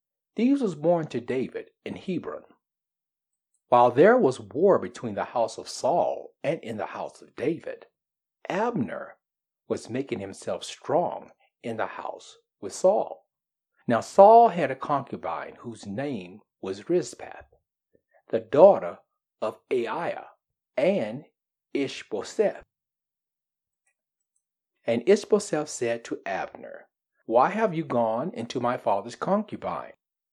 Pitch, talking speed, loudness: 165 Hz, 120 wpm, -25 LUFS